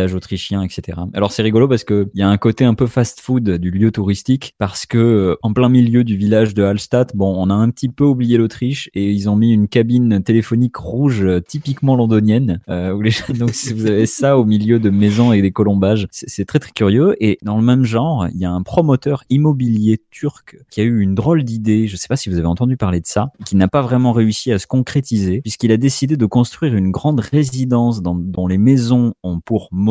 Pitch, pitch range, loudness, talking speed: 110 Hz, 100-125 Hz, -15 LUFS, 230 wpm